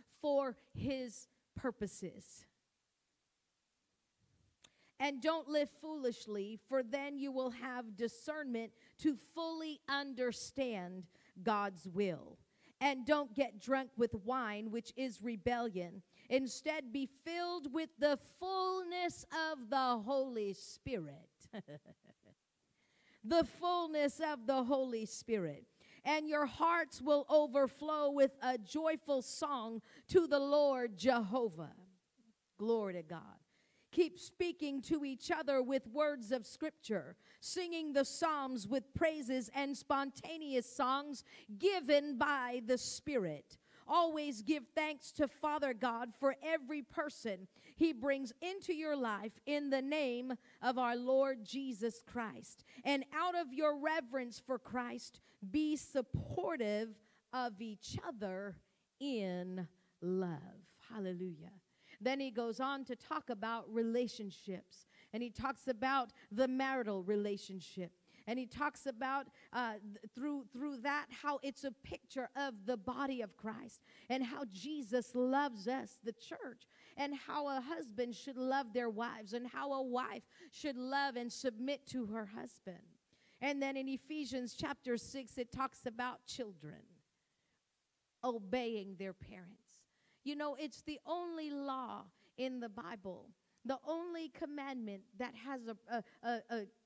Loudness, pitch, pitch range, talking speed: -40 LUFS, 260 Hz, 225-285 Hz, 130 wpm